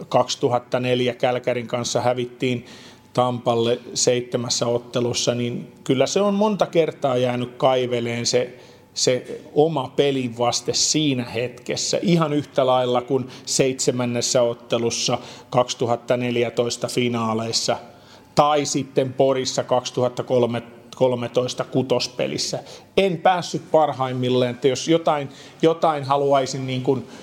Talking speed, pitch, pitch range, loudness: 95 wpm, 125 Hz, 120-135 Hz, -21 LUFS